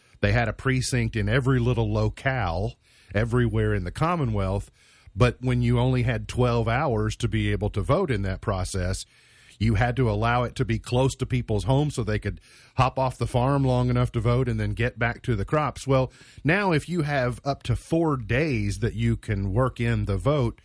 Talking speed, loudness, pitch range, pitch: 210 wpm, -25 LUFS, 105-130 Hz, 120 Hz